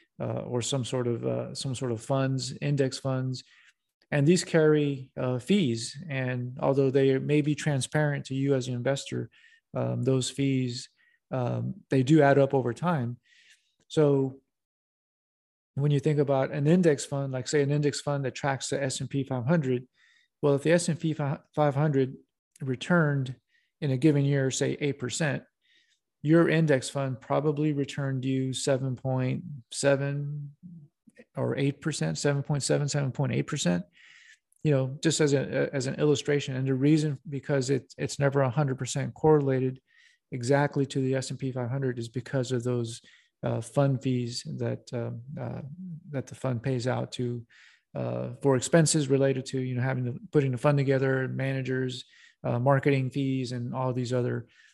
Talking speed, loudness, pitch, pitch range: 160 wpm, -28 LUFS, 135 Hz, 130-145 Hz